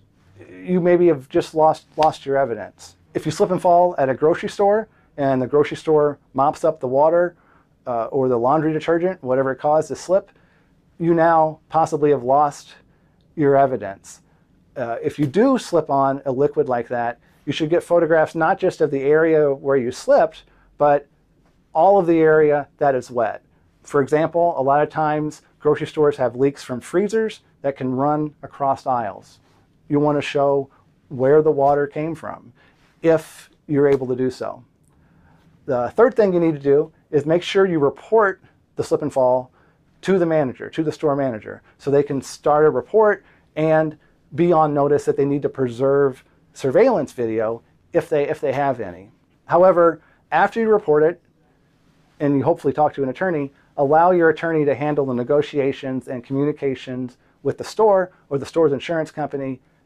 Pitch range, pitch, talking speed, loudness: 140-160 Hz, 150 Hz, 180 wpm, -19 LUFS